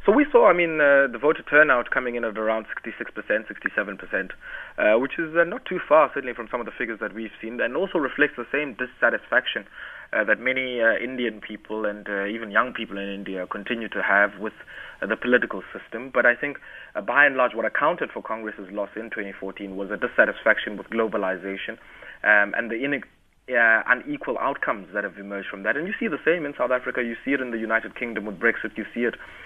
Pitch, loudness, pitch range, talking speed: 110 Hz, -23 LUFS, 100-125 Hz, 220 wpm